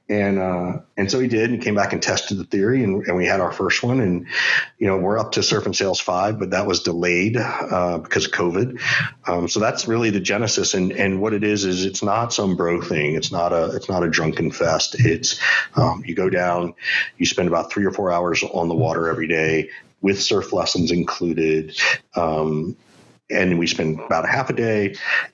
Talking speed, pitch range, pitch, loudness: 220 wpm, 85-100 Hz, 90 Hz, -20 LUFS